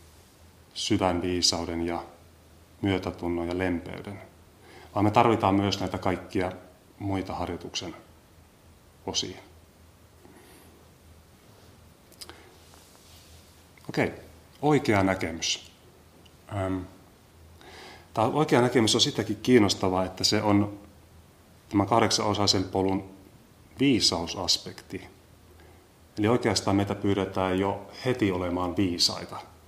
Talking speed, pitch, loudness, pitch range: 80 wpm, 95 Hz, -26 LUFS, 85-100 Hz